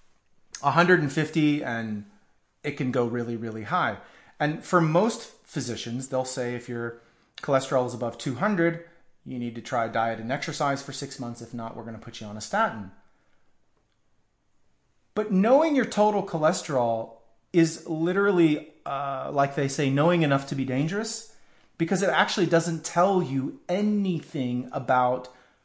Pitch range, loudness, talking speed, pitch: 120-170 Hz, -26 LUFS, 150 wpm, 140 Hz